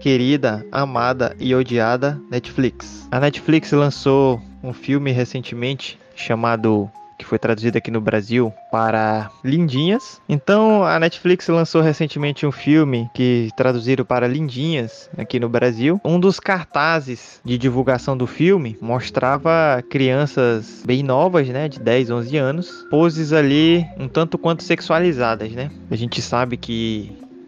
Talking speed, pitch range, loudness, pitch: 135 wpm, 120-160 Hz, -18 LUFS, 130 Hz